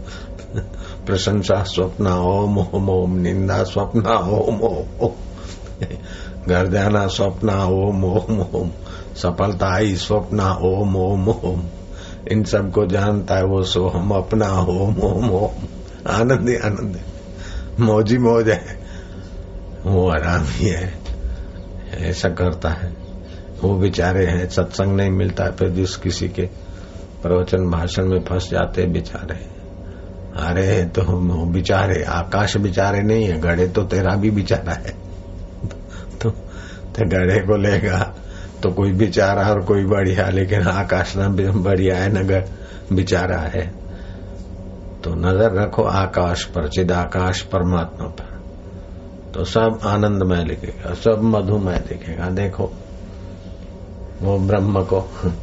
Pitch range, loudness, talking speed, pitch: 90-100 Hz, -19 LUFS, 130 wpm, 95 Hz